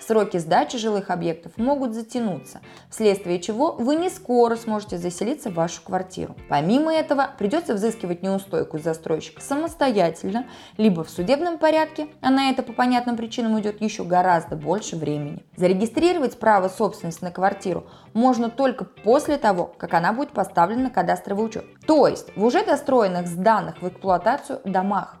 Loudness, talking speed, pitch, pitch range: -22 LUFS, 150 wpm, 215 Hz, 180-255 Hz